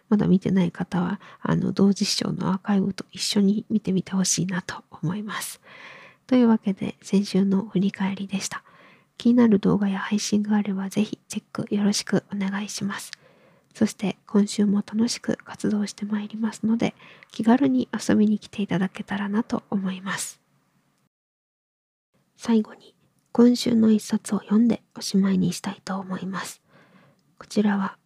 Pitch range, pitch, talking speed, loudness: 190-215 Hz, 200 Hz, 325 characters per minute, -24 LUFS